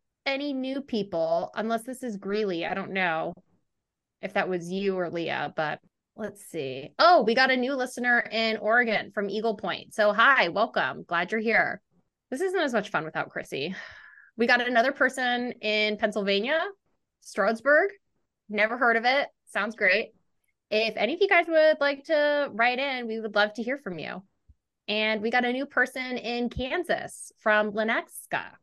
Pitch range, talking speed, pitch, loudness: 210-260 Hz, 175 wpm, 225 Hz, -26 LUFS